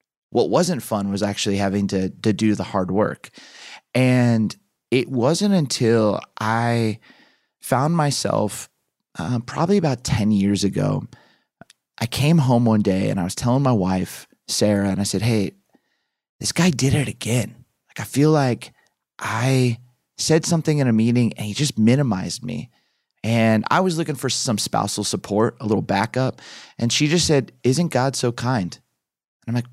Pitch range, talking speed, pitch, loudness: 105-140 Hz, 170 wpm, 120 Hz, -20 LUFS